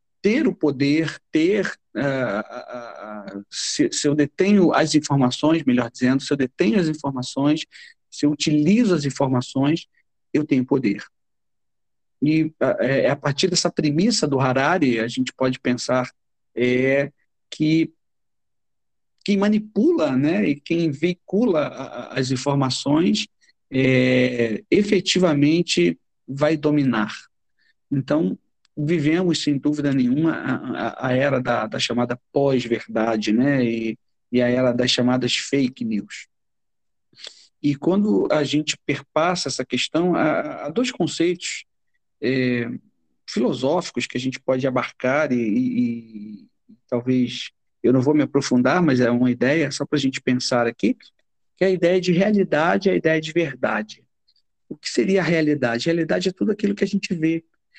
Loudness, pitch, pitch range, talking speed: -21 LUFS, 145 Hz, 125-170 Hz, 140 wpm